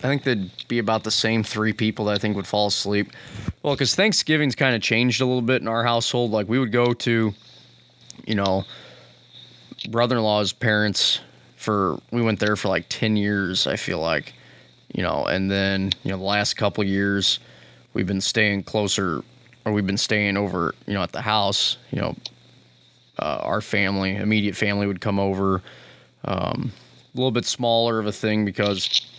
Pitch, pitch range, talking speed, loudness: 105 Hz, 100-115 Hz, 190 wpm, -22 LUFS